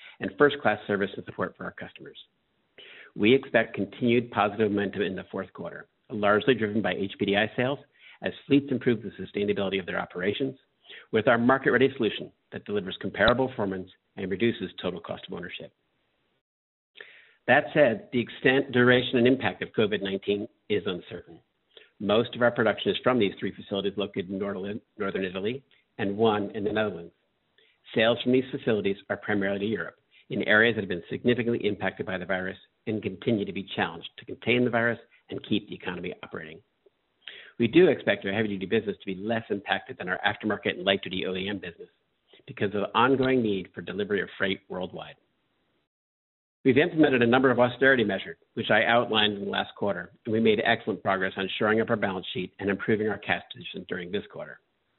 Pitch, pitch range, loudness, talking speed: 110 Hz, 100-125 Hz, -26 LUFS, 185 wpm